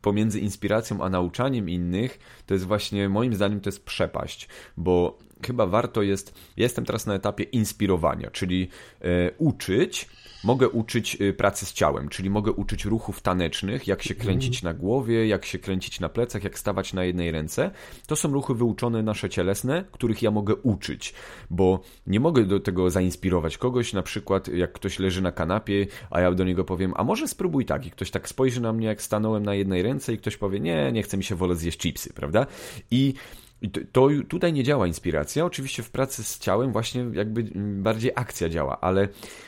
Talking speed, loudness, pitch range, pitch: 185 wpm, -26 LUFS, 95-115 Hz, 100 Hz